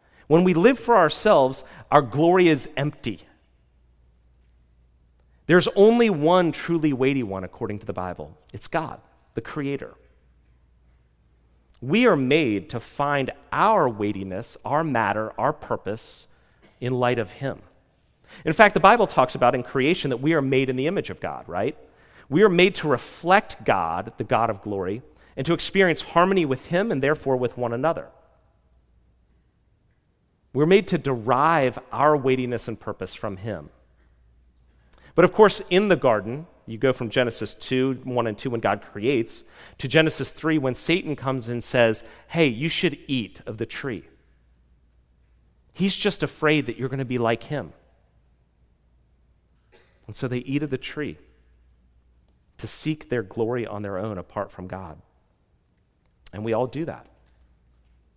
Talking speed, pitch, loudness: 155 wpm, 120 Hz, -23 LUFS